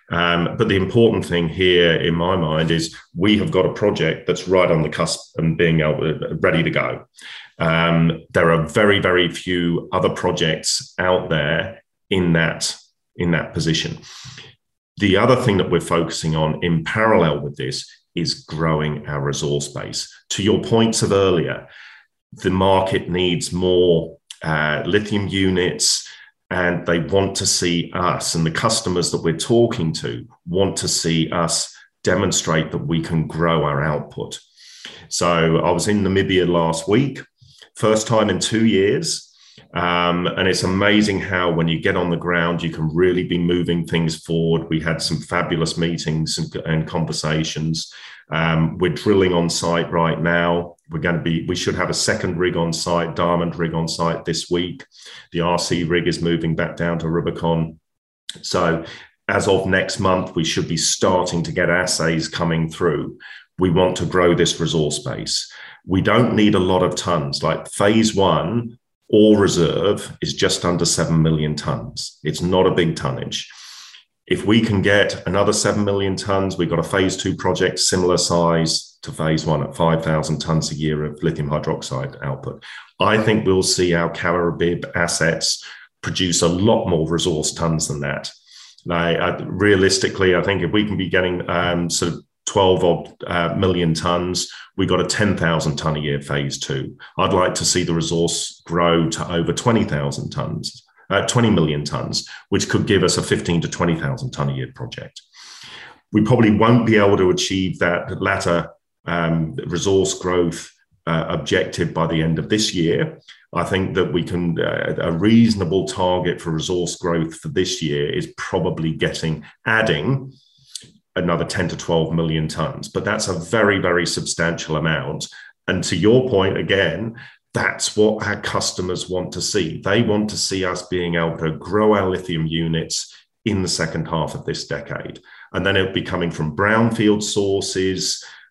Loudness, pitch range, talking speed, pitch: -19 LUFS, 80-95 Hz, 170 wpm, 85 Hz